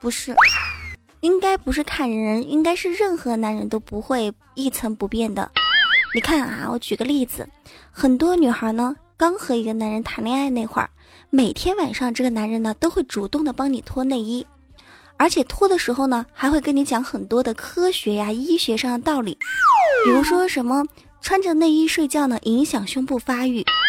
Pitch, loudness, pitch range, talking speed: 260 Hz, -20 LUFS, 230-320 Hz, 275 characters per minute